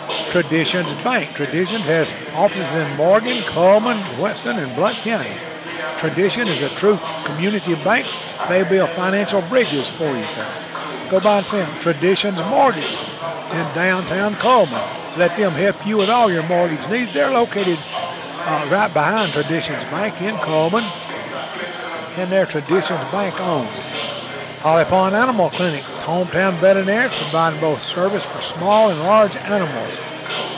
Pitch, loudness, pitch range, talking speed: 180 Hz, -18 LUFS, 160-205 Hz, 140 wpm